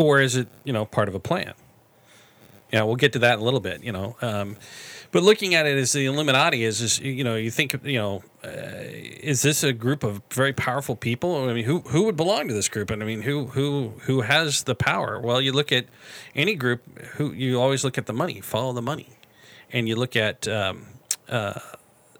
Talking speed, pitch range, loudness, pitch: 230 wpm, 115-140 Hz, -23 LUFS, 130 Hz